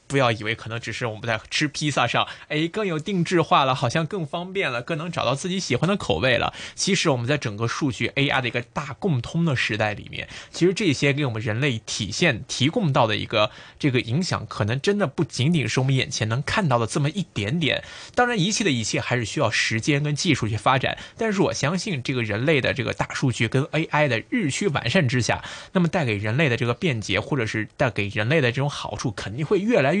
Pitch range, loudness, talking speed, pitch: 115-165 Hz, -23 LUFS, 355 characters per minute, 140 Hz